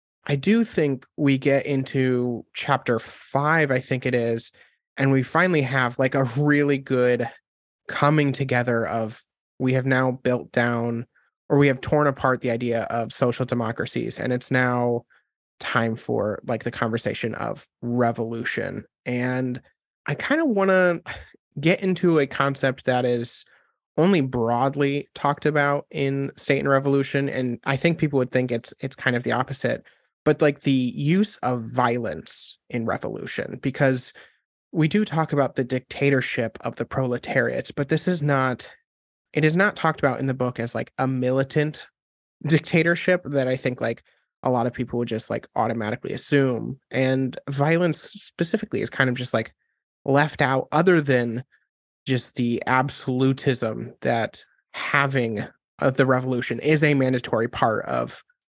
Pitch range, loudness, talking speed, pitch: 125-145 Hz, -23 LUFS, 155 wpm, 130 Hz